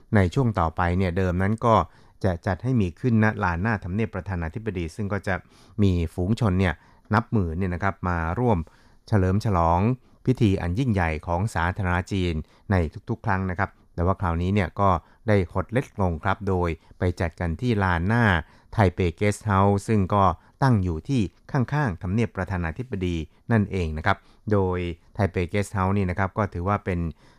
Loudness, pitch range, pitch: -25 LUFS, 90-110 Hz, 95 Hz